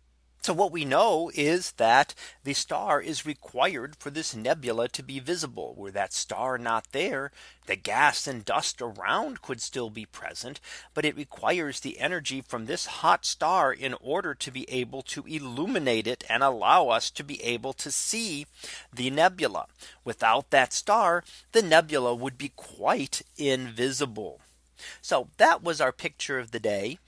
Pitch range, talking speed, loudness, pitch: 120-150 Hz, 165 wpm, -27 LUFS, 135 Hz